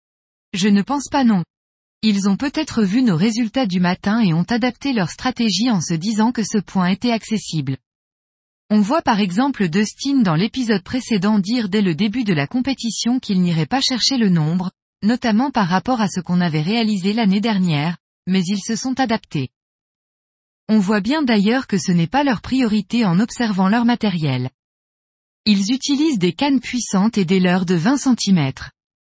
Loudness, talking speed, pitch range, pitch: -18 LUFS, 180 wpm, 185-245 Hz, 215 Hz